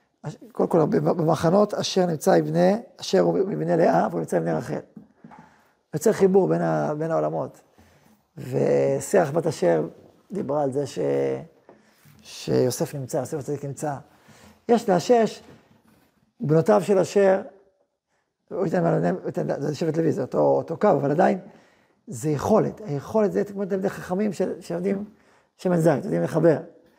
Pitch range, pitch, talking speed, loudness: 140-195 Hz, 165 Hz, 135 wpm, -23 LUFS